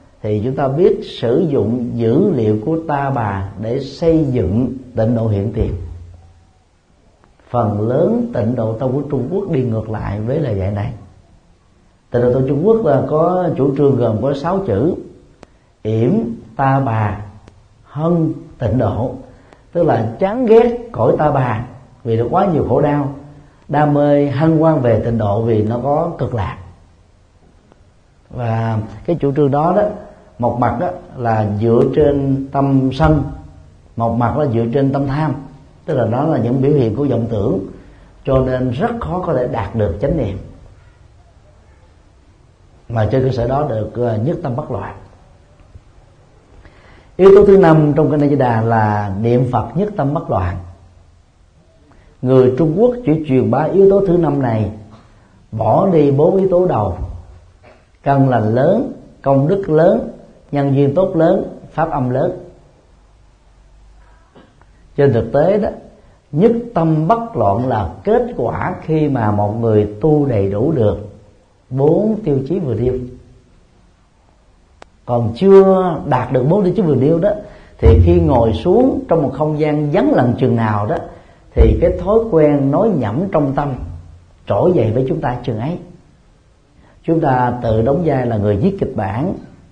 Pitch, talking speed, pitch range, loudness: 125 Hz, 165 wpm, 105-150 Hz, -15 LUFS